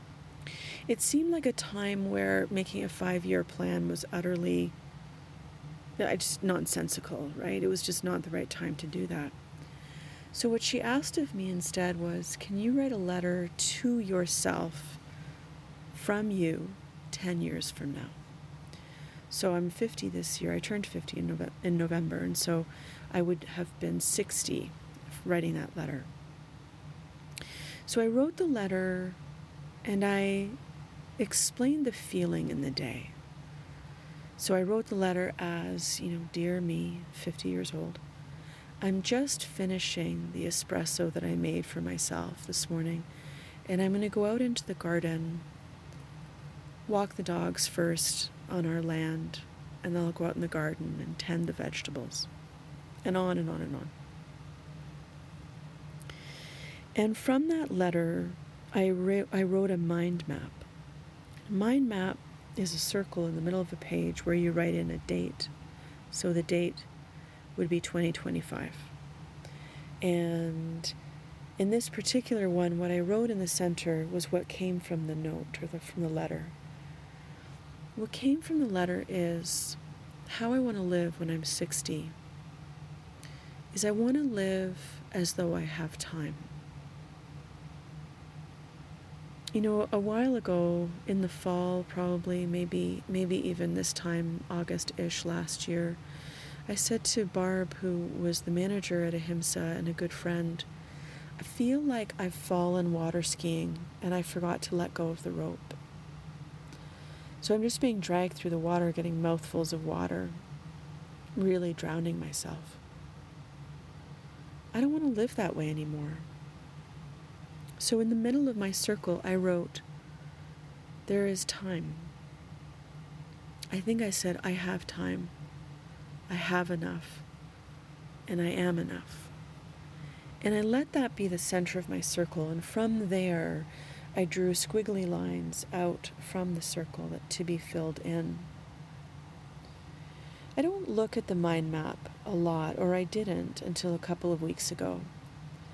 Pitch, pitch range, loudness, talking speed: 165 Hz, 150-180 Hz, -32 LUFS, 150 wpm